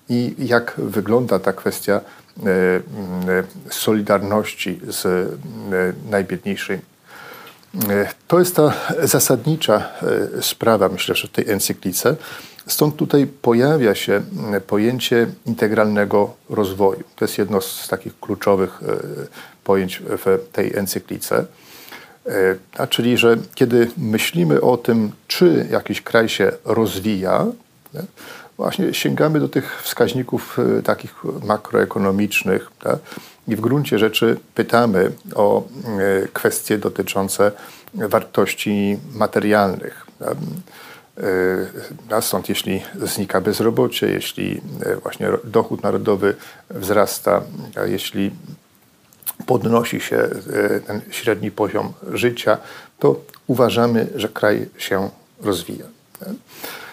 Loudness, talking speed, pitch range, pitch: -19 LUFS, 95 wpm, 100-120 Hz, 110 Hz